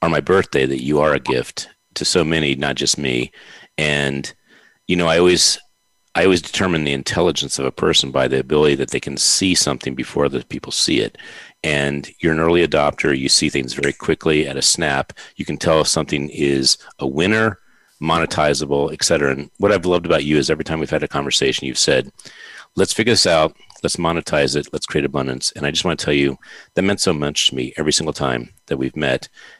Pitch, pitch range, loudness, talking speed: 75 Hz, 70-80 Hz, -18 LUFS, 215 wpm